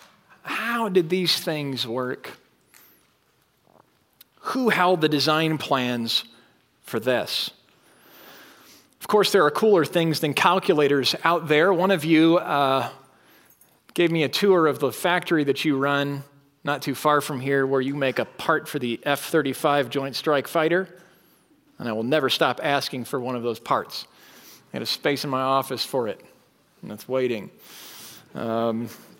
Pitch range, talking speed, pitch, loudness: 135-165 Hz, 160 wpm, 145 Hz, -23 LUFS